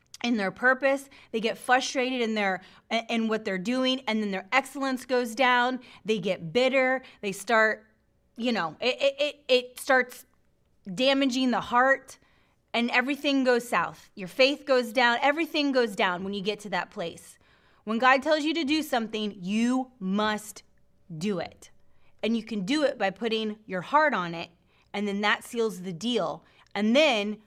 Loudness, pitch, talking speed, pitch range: -26 LUFS, 235 Hz, 175 wpm, 210-260 Hz